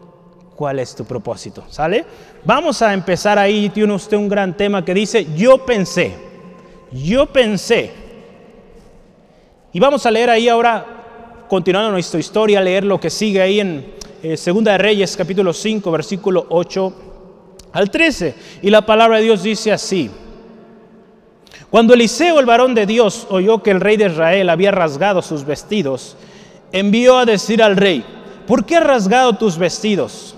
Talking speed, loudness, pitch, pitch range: 160 wpm, -14 LUFS, 205 Hz, 185-220 Hz